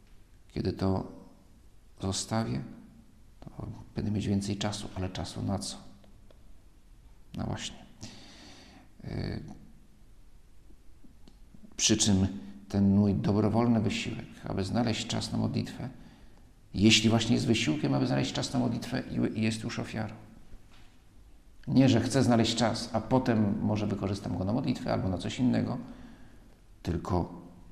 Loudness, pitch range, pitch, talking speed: -29 LUFS, 100-115 Hz, 110 Hz, 120 wpm